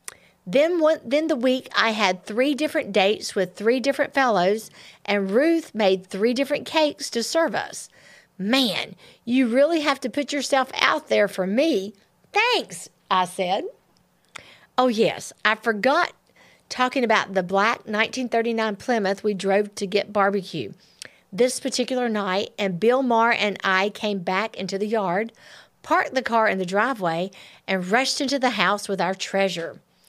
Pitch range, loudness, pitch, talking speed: 200-265 Hz, -22 LUFS, 225 Hz, 160 wpm